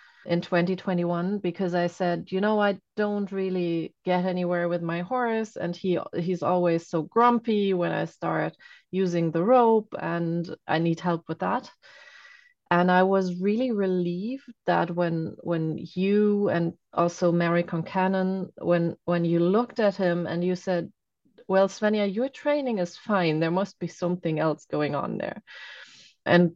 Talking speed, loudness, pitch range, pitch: 160 wpm, -26 LUFS, 170-200 Hz, 180 Hz